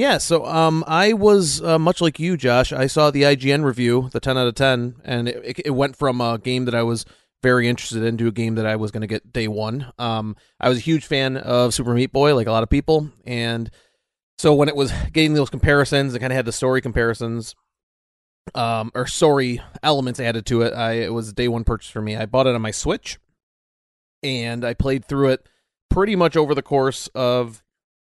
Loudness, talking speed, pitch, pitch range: -20 LUFS, 230 wpm, 125 Hz, 115-140 Hz